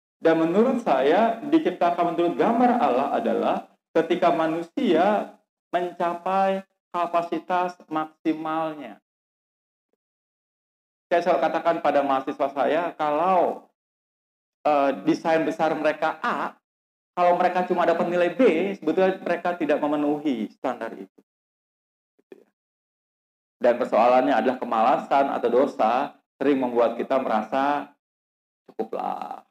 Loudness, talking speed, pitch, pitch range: -23 LUFS, 100 wpm, 170 Hz, 155-180 Hz